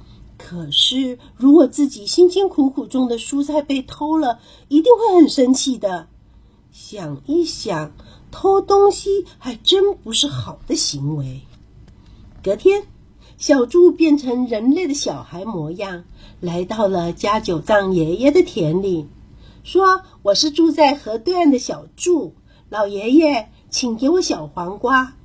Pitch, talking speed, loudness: 255 Hz, 195 characters per minute, -17 LUFS